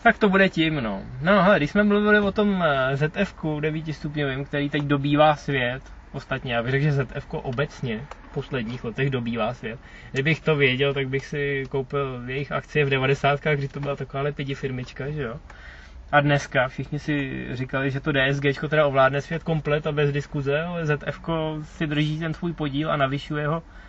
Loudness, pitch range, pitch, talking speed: -24 LUFS, 135-155 Hz, 145 Hz, 190 wpm